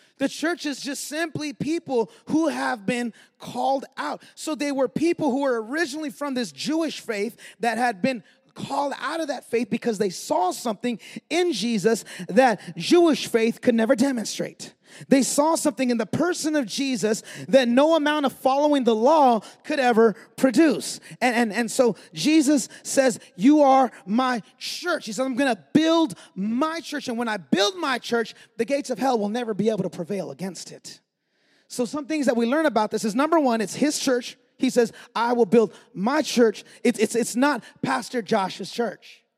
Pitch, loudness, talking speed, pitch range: 250 Hz, -23 LUFS, 190 wpm, 230-290 Hz